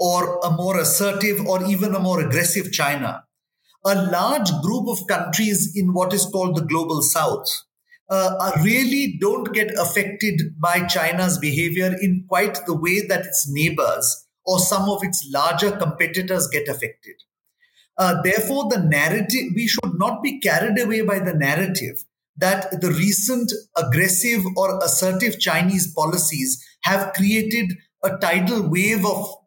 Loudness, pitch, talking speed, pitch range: -20 LUFS, 190 Hz, 145 wpm, 175-205 Hz